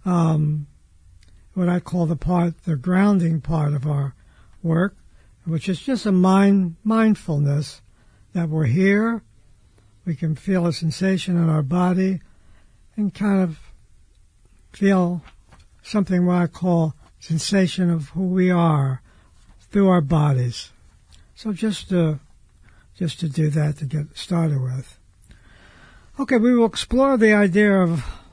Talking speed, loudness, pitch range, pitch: 135 wpm, -21 LUFS, 135-185 Hz, 165 Hz